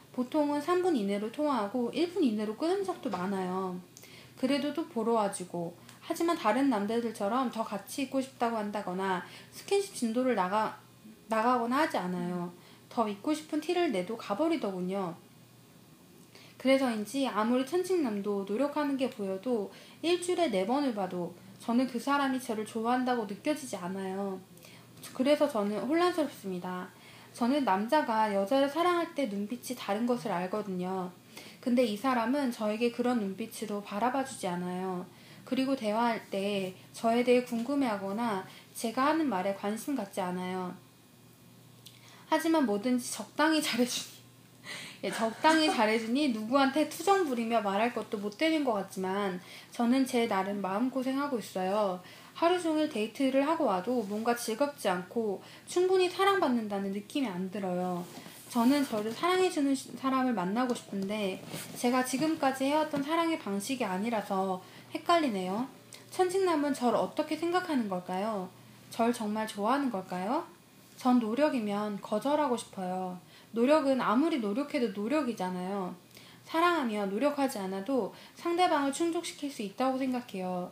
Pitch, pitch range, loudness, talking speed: 240 Hz, 200-285 Hz, -31 LUFS, 320 characters per minute